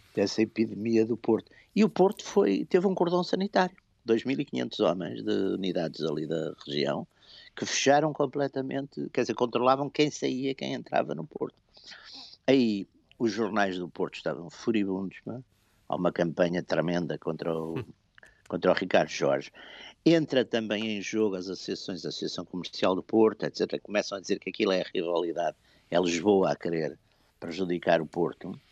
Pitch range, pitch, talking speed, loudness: 95-140 Hz, 115 Hz, 160 wpm, -29 LUFS